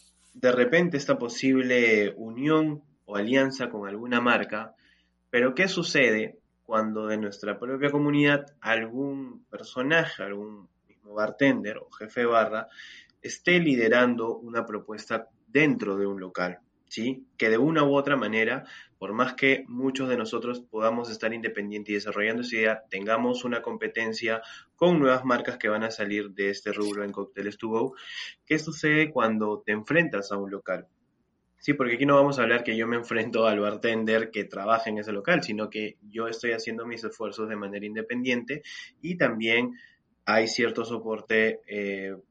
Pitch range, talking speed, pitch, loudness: 105-130 Hz, 160 wpm, 115 Hz, -26 LUFS